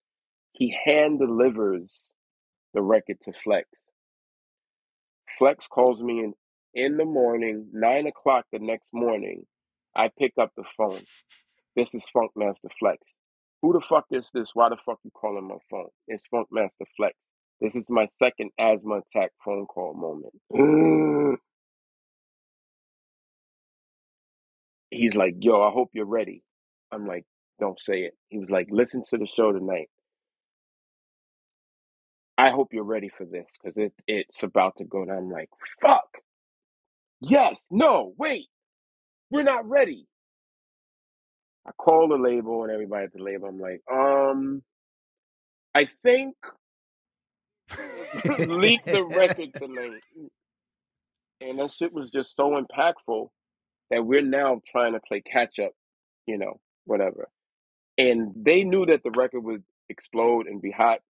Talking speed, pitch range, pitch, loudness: 140 wpm, 110-155 Hz, 125 Hz, -24 LUFS